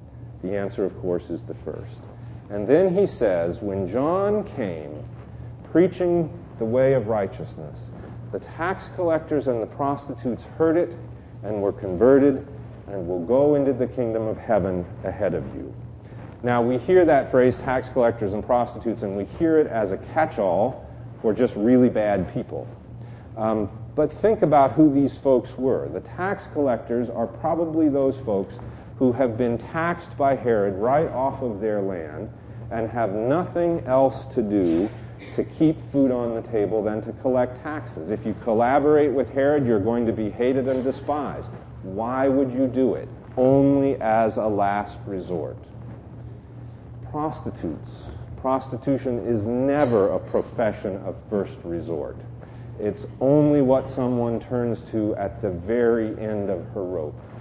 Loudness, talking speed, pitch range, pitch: -23 LUFS, 155 wpm, 110-135 Hz, 120 Hz